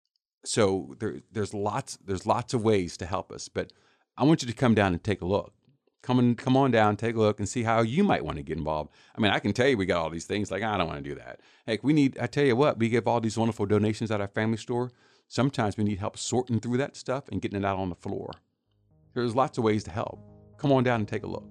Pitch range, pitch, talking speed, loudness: 100-120 Hz, 110 Hz, 285 wpm, -27 LUFS